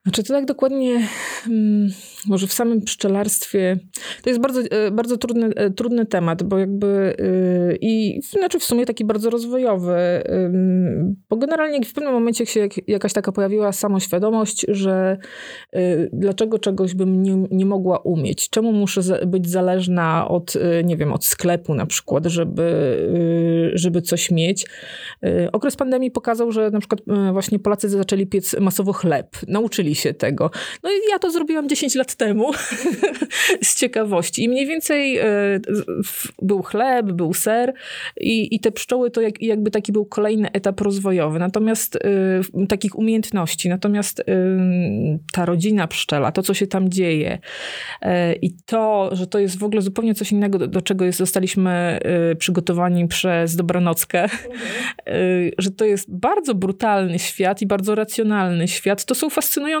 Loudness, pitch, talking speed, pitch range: -19 LUFS, 200 Hz, 150 wpm, 185-225 Hz